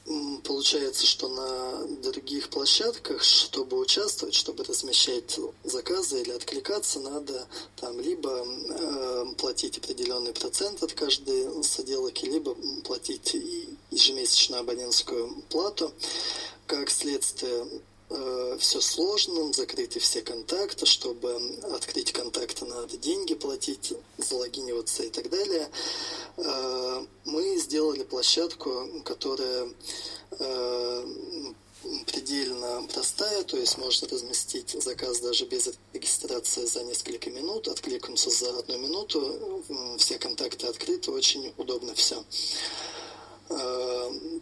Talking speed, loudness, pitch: 95 wpm, -27 LUFS, 370 Hz